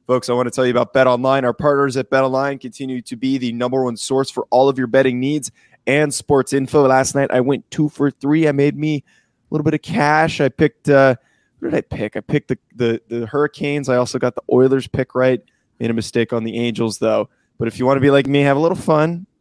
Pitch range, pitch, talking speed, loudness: 125-145 Hz, 135 Hz, 260 wpm, -17 LUFS